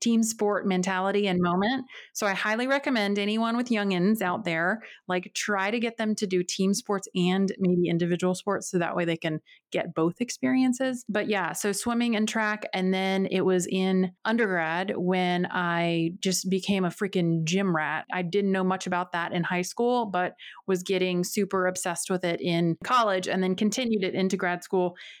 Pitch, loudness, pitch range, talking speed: 190 Hz, -27 LUFS, 180-210 Hz, 190 wpm